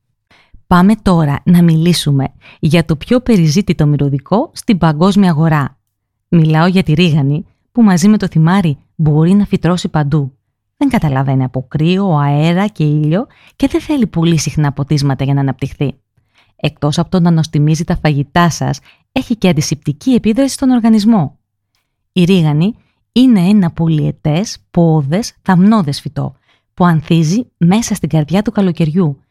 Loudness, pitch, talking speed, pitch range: -13 LUFS, 165 Hz, 145 wpm, 145-190 Hz